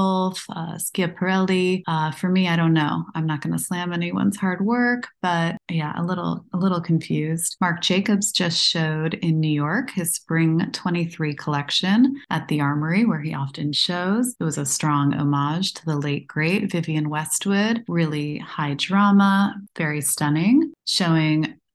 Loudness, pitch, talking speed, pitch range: -22 LUFS, 170 Hz, 155 wpm, 155-190 Hz